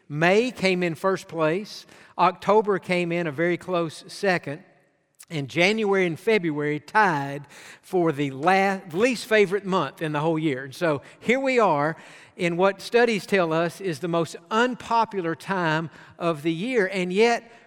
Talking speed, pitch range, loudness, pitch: 160 wpm, 160-200 Hz, -23 LUFS, 180 Hz